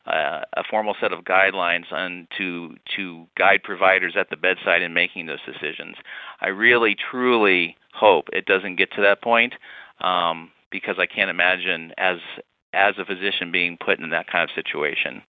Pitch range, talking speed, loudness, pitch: 85-100 Hz, 170 wpm, -21 LUFS, 90 Hz